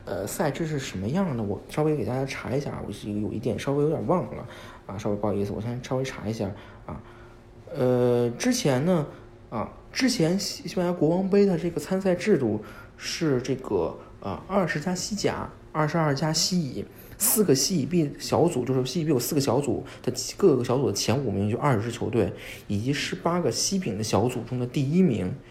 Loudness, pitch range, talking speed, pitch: -26 LUFS, 110-165 Hz, 295 characters per minute, 130 Hz